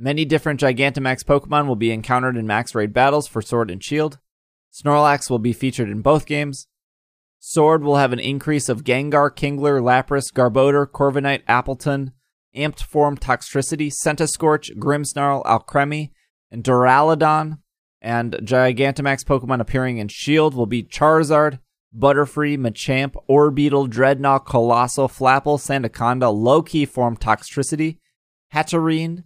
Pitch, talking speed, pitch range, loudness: 140 Hz, 130 wpm, 125-150 Hz, -18 LUFS